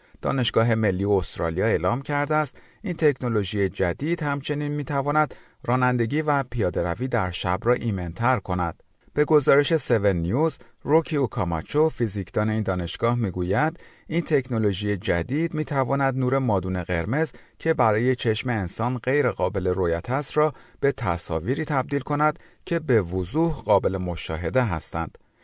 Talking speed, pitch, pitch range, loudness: 130 wpm, 125 Hz, 100-145 Hz, -24 LUFS